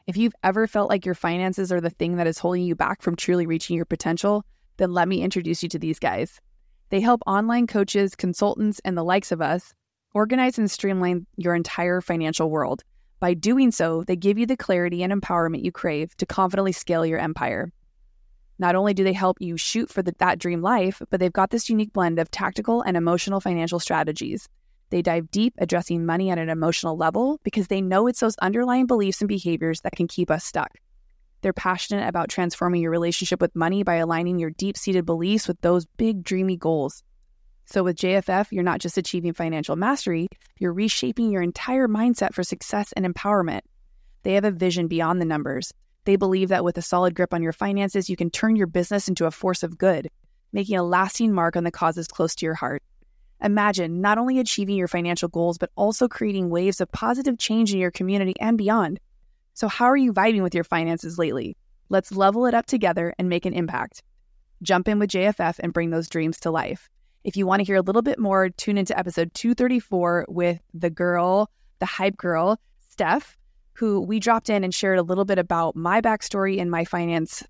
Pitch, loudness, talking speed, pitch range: 185 Hz, -23 LUFS, 205 wpm, 170-205 Hz